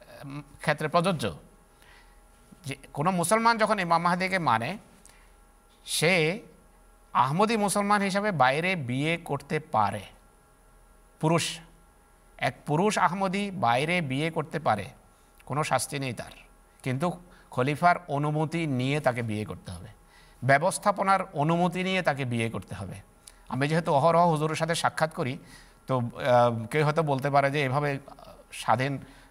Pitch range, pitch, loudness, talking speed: 125-170 Hz, 145 Hz, -26 LUFS, 120 wpm